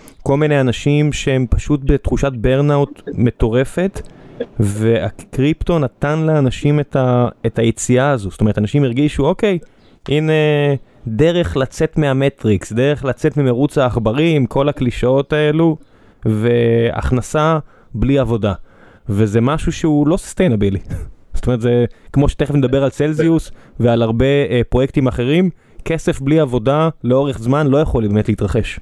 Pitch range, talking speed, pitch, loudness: 120-150 Hz, 130 wpm, 135 Hz, -16 LUFS